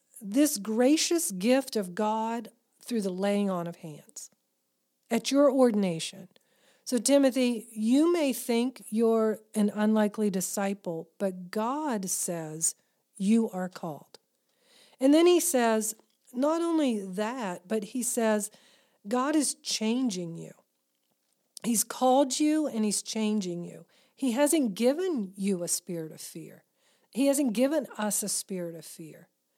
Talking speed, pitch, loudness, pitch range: 135 wpm, 220 Hz, -28 LUFS, 195-260 Hz